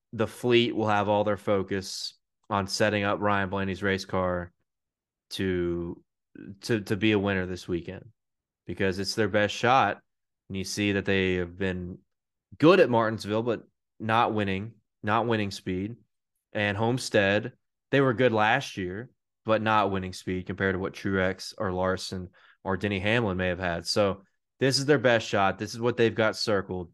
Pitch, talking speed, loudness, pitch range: 100 Hz, 175 wpm, -27 LUFS, 95-110 Hz